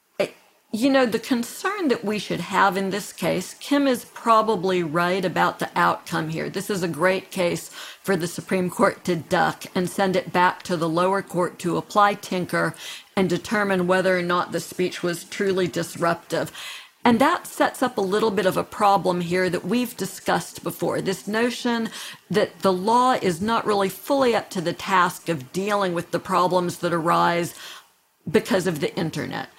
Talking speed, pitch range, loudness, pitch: 185 wpm, 175-210 Hz, -23 LUFS, 190 Hz